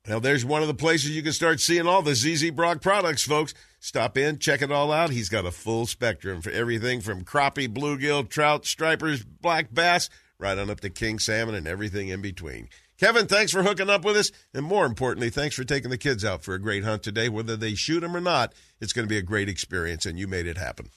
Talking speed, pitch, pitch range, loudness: 245 wpm, 130 Hz, 110-155 Hz, -25 LUFS